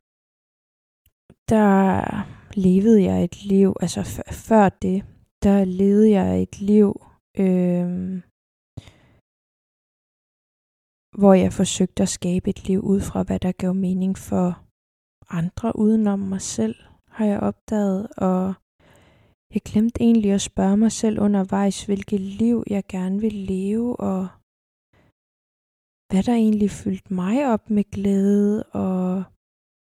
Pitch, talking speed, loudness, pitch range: 195 Hz, 125 wpm, -21 LUFS, 185-205 Hz